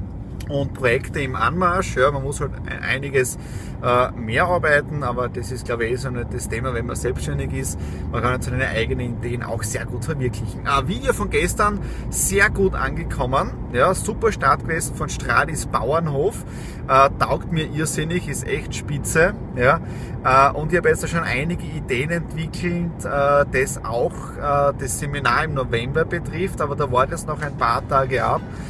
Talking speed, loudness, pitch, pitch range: 175 wpm, -21 LUFS, 135 Hz, 120-150 Hz